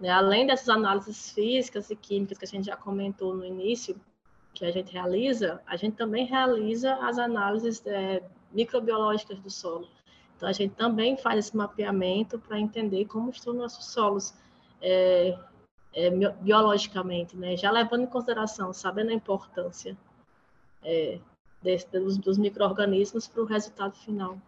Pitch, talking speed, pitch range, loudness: 205 Hz, 145 wpm, 190-225 Hz, -28 LUFS